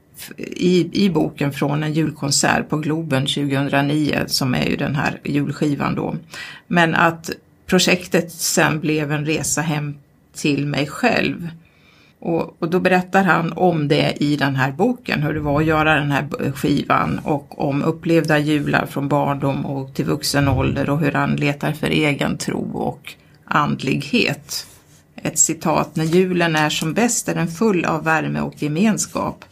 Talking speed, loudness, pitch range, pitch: 160 wpm, -19 LUFS, 145-170 Hz, 155 Hz